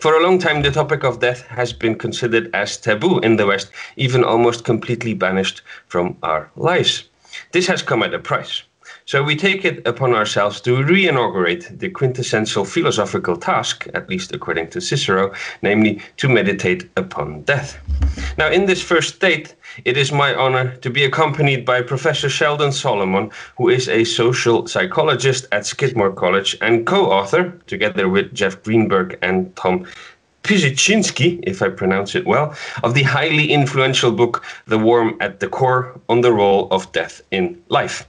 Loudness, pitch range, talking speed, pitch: -17 LUFS, 110-155 Hz, 170 wpm, 130 Hz